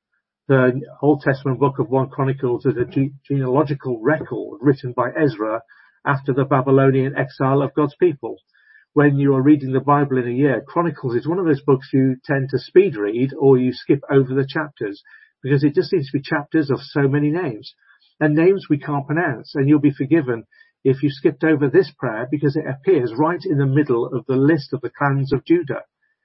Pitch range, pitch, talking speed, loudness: 135-155 Hz, 140 Hz, 200 wpm, -19 LUFS